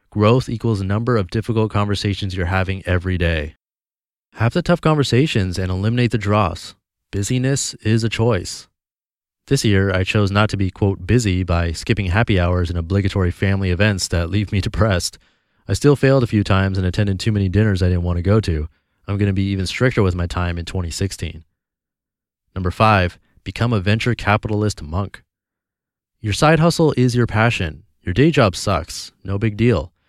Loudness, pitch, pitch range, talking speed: -18 LUFS, 100 Hz, 90-115 Hz, 185 wpm